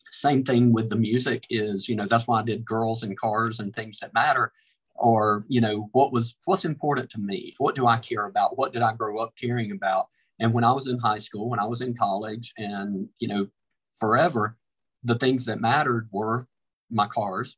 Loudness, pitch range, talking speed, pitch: -25 LUFS, 105-120 Hz, 215 wpm, 115 Hz